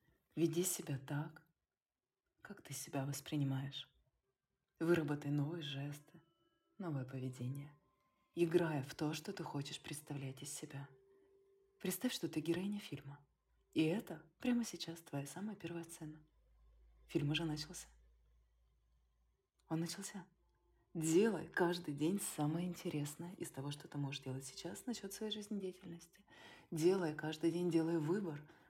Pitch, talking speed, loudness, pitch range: 160 Hz, 125 wpm, -41 LUFS, 140-175 Hz